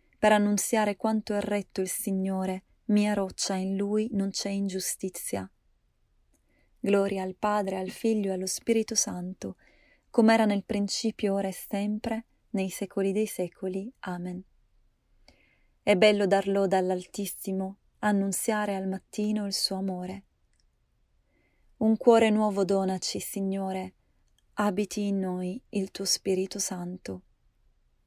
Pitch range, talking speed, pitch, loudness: 190-210 Hz, 125 wpm, 195 Hz, -28 LUFS